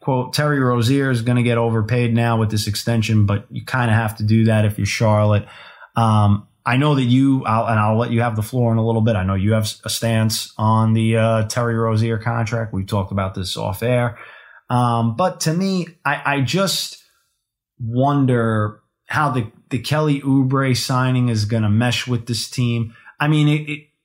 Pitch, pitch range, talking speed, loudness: 115 Hz, 110-130 Hz, 205 wpm, -19 LUFS